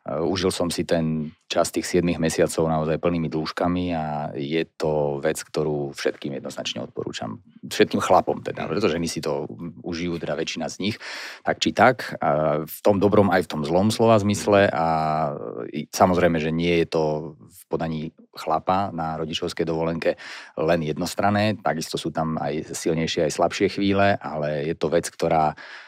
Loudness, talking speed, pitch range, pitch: -23 LUFS, 160 wpm, 80-90 Hz, 80 Hz